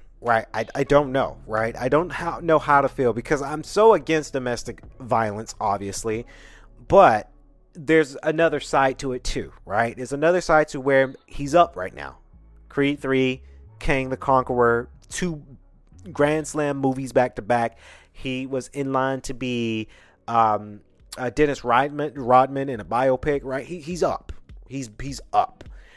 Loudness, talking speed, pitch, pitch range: -22 LUFS, 160 wpm, 130 Hz, 115-145 Hz